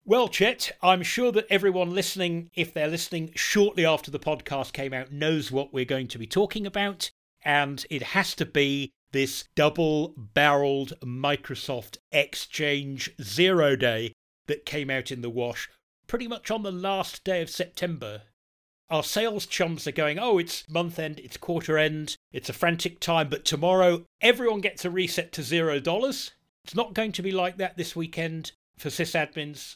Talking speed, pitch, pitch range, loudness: 175 wpm, 160 Hz, 140-185 Hz, -26 LUFS